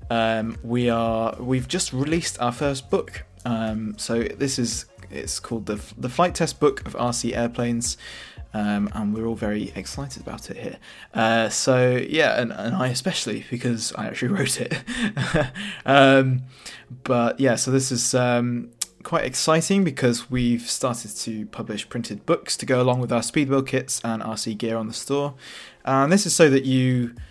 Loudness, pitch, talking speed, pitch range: -23 LUFS, 120 Hz, 175 wpm, 115-135 Hz